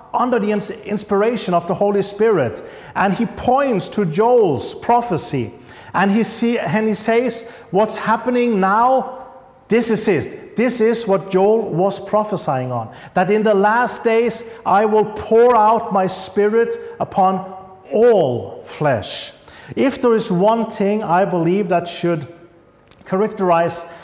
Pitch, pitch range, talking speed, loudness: 215 Hz, 190-235 Hz, 135 wpm, -17 LUFS